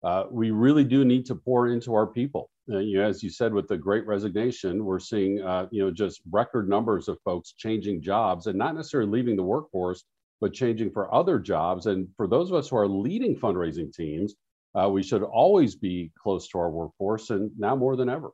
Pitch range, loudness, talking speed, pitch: 95-120 Hz, -26 LUFS, 220 wpm, 105 Hz